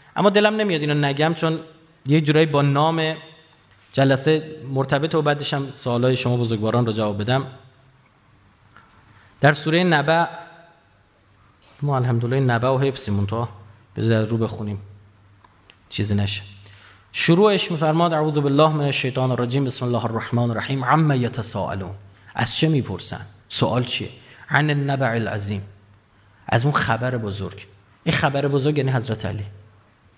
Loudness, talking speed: -21 LUFS, 130 wpm